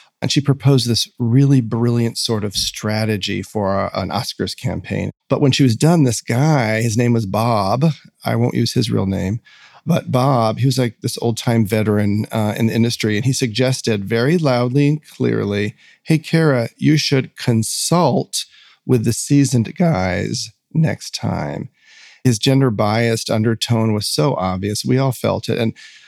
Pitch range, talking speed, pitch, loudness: 110-135 Hz, 170 wpm, 115 Hz, -18 LUFS